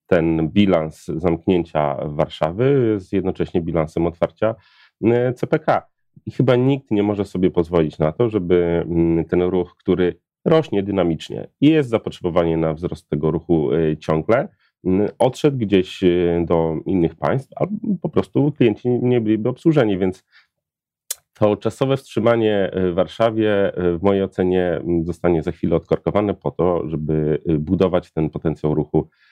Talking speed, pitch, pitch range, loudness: 130 wpm, 90 Hz, 85-110 Hz, -19 LUFS